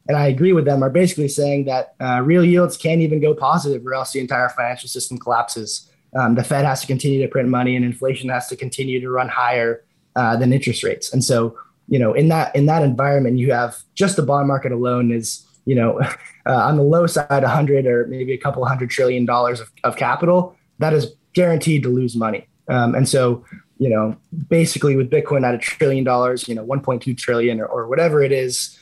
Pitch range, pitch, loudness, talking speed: 125-150 Hz, 130 Hz, -18 LUFS, 225 wpm